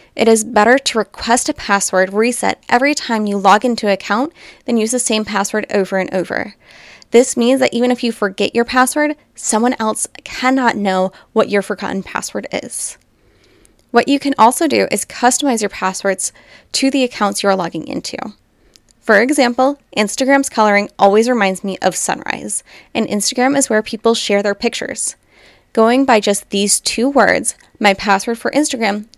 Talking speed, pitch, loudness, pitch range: 175 wpm, 225 Hz, -15 LUFS, 200-250 Hz